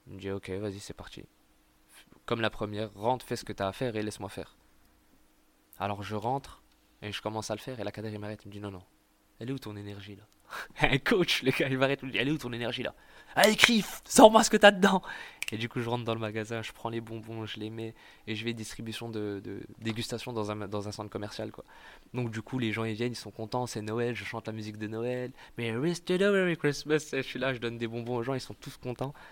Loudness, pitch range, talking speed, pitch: -30 LUFS, 105-125 Hz, 265 wpm, 115 Hz